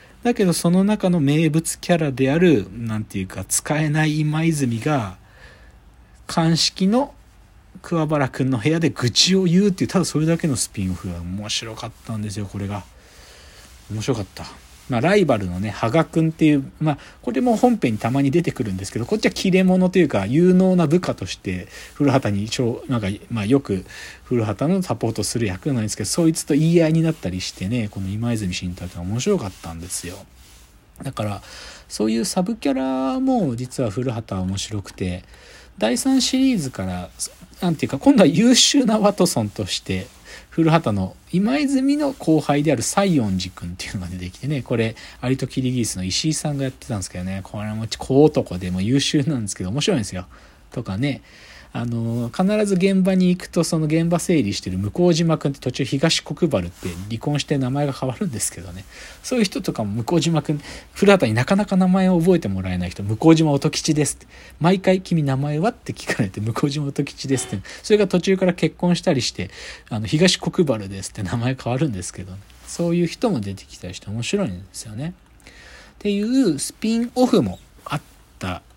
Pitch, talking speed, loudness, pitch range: 135 Hz, 360 characters per minute, -20 LUFS, 100-170 Hz